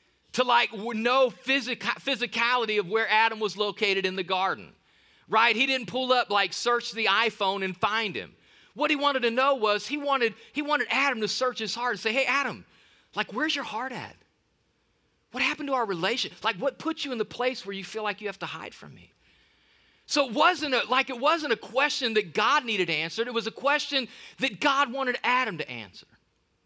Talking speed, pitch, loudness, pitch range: 210 wpm, 240 Hz, -26 LUFS, 215-270 Hz